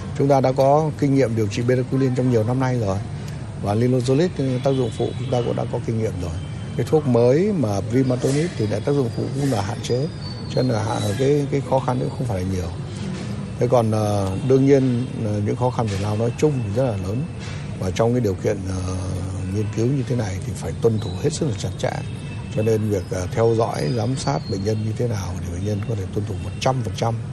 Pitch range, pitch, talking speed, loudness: 105-130 Hz, 120 Hz, 240 wpm, -22 LUFS